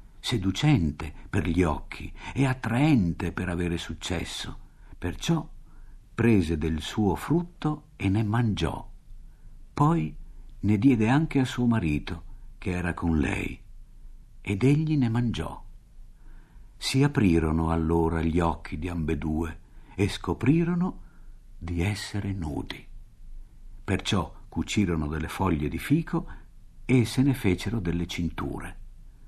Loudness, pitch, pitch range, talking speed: -27 LUFS, 95 Hz, 85-120 Hz, 115 wpm